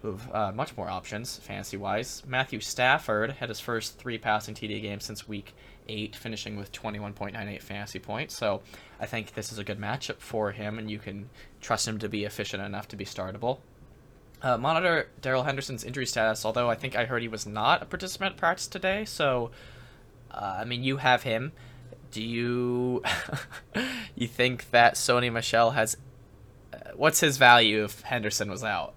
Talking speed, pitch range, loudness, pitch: 180 wpm, 105-125 Hz, -28 LUFS, 115 Hz